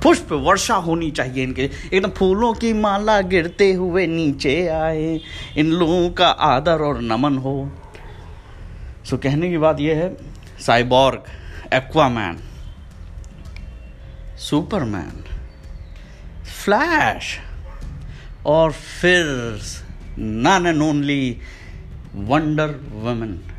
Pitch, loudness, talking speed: 135 Hz, -19 LUFS, 95 wpm